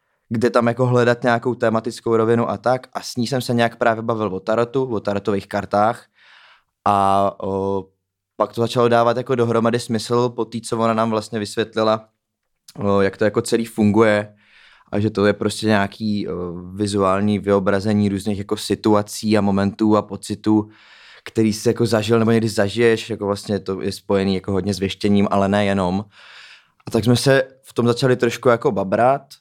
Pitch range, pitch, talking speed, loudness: 100-115 Hz, 110 Hz, 180 wpm, -19 LUFS